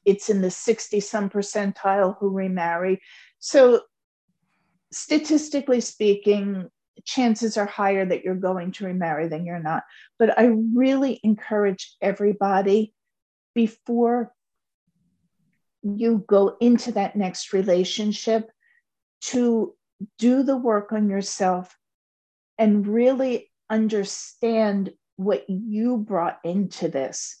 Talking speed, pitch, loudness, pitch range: 105 wpm, 205 Hz, -23 LUFS, 185-230 Hz